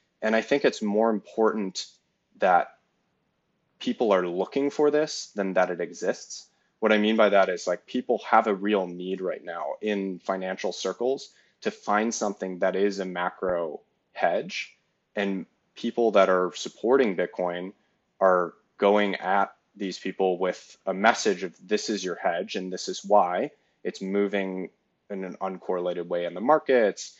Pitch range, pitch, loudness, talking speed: 95-110 Hz, 100 Hz, -26 LUFS, 160 wpm